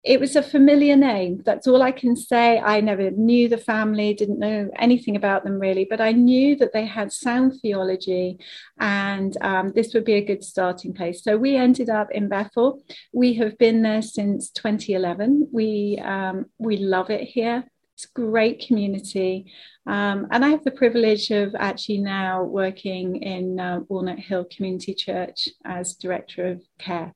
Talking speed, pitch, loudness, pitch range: 175 wpm, 210 Hz, -21 LUFS, 190-240 Hz